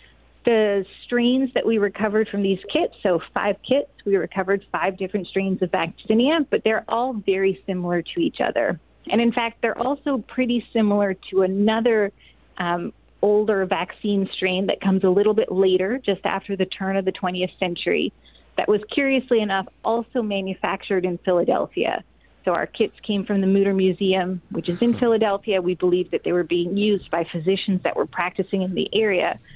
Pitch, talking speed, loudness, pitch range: 195 Hz, 180 wpm, -22 LUFS, 190-220 Hz